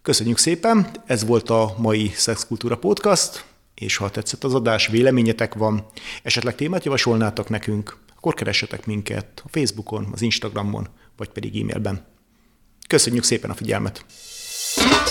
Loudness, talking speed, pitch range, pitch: -21 LUFS, 130 wpm, 105-120 Hz, 110 Hz